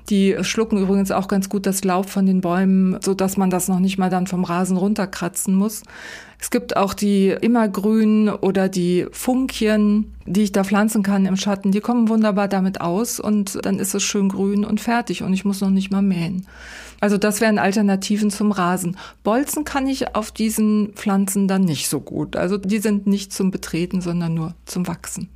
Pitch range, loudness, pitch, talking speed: 190-210 Hz, -20 LUFS, 200 Hz, 200 wpm